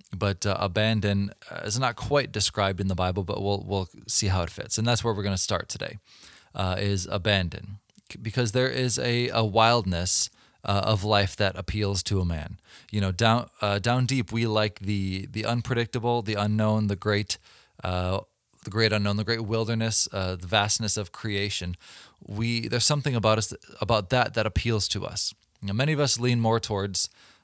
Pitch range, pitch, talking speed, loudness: 100-115 Hz, 105 Hz, 190 wpm, -25 LUFS